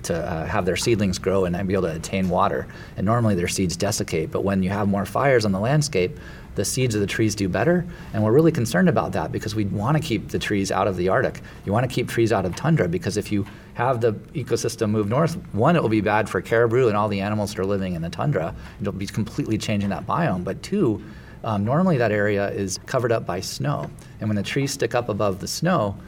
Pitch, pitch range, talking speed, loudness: 105 Hz, 95-115 Hz, 255 wpm, -23 LUFS